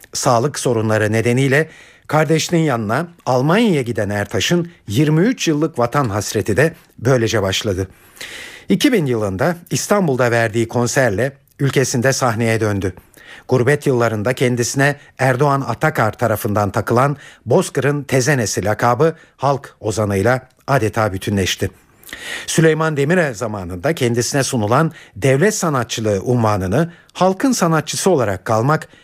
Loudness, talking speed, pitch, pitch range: -17 LUFS, 100 wpm, 130 Hz, 115-155 Hz